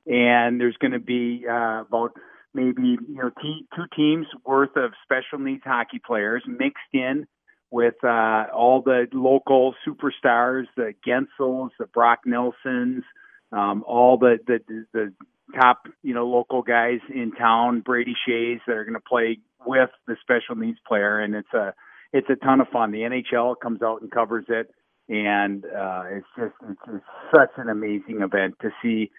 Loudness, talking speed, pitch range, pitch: -22 LUFS, 170 wpm, 115-130 Hz, 120 Hz